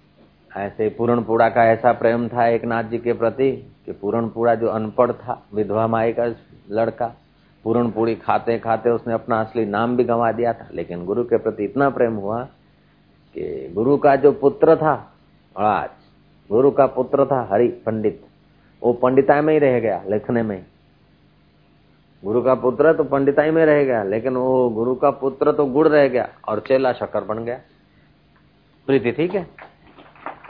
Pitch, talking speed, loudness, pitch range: 120 Hz, 165 wpm, -19 LUFS, 115-135 Hz